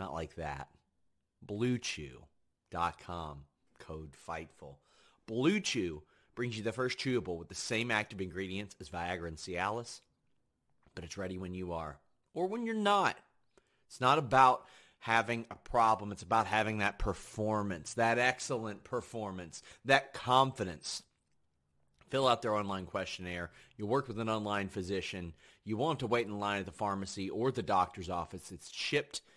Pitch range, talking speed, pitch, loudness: 85-115 Hz, 155 wpm, 100 Hz, -34 LUFS